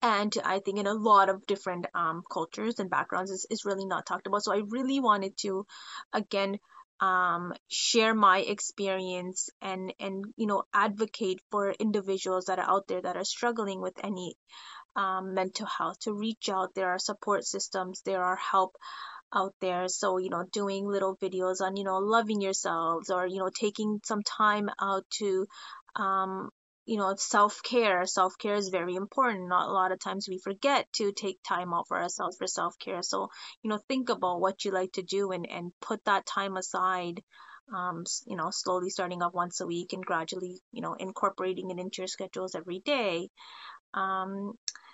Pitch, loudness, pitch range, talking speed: 190 Hz, -30 LUFS, 185-205 Hz, 185 wpm